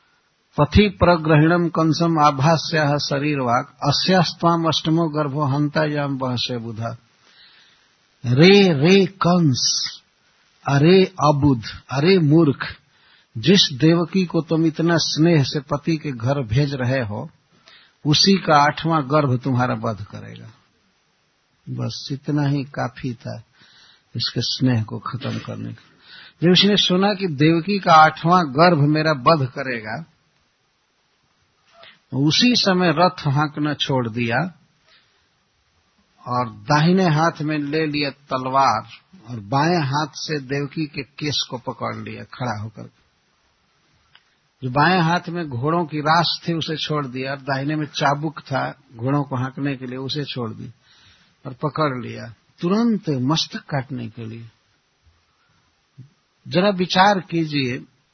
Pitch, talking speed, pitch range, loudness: 150 Hz, 125 wpm, 130-165 Hz, -19 LUFS